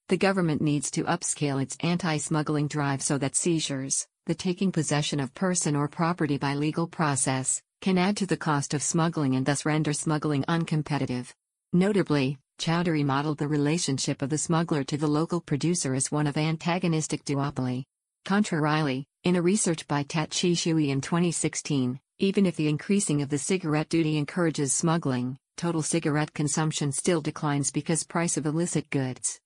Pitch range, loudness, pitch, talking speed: 145-170 Hz, -27 LUFS, 155 Hz, 160 wpm